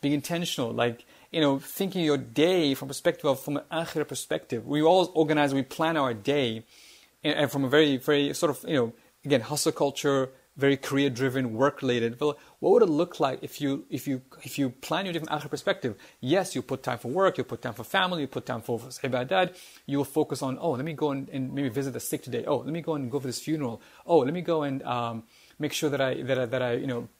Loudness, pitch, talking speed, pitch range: -28 LUFS, 140 Hz, 250 wpm, 130-155 Hz